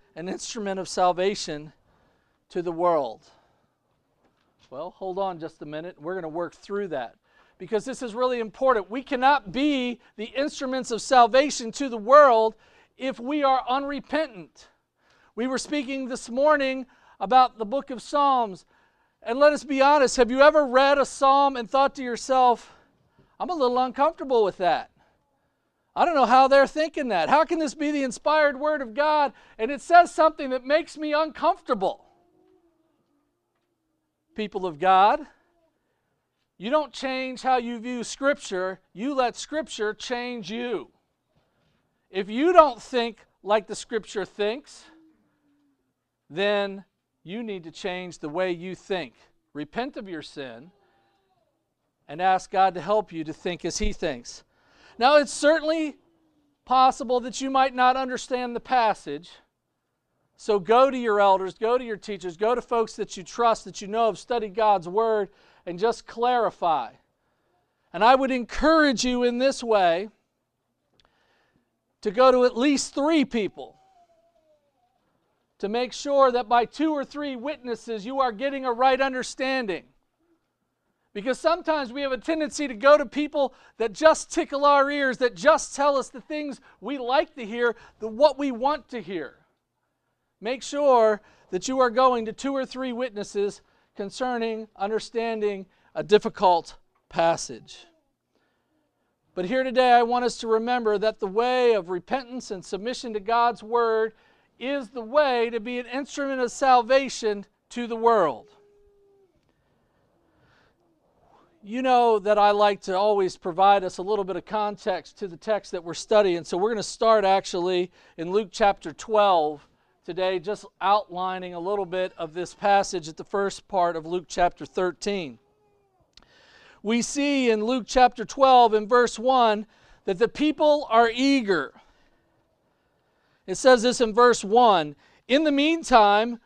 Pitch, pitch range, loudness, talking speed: 240 Hz, 205-275 Hz, -23 LUFS, 155 wpm